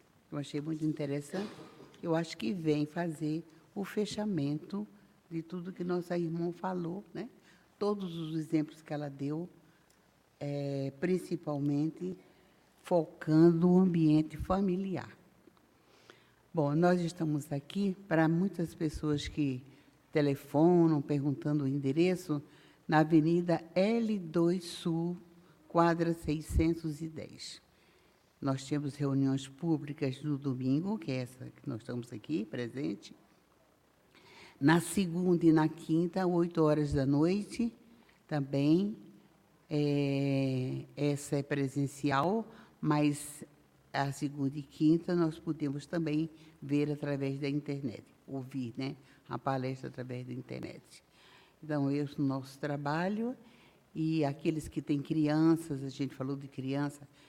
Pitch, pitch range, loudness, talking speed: 155 Hz, 140-170 Hz, -33 LUFS, 115 wpm